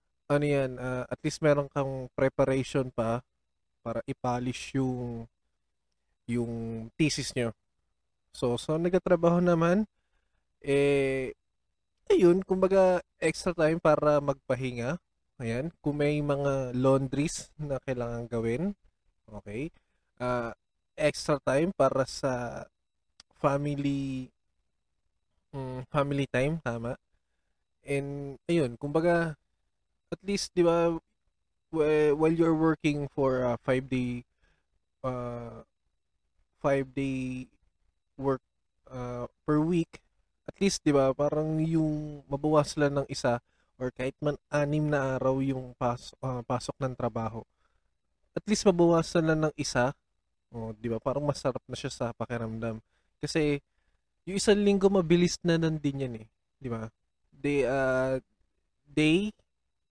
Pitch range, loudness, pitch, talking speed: 120-150 Hz, -29 LUFS, 135 Hz, 120 wpm